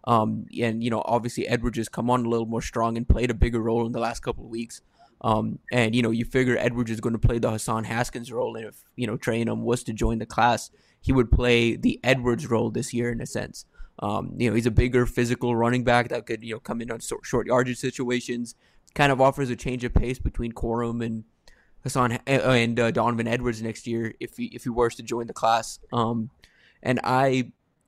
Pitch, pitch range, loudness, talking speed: 120 Hz, 115-125 Hz, -25 LUFS, 240 wpm